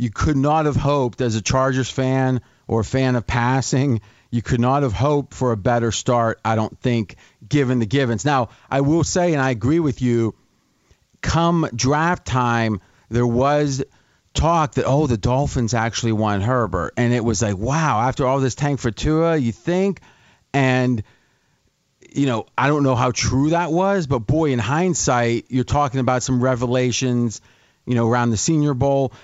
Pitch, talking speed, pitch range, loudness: 130 Hz, 180 wpm, 120-140 Hz, -20 LUFS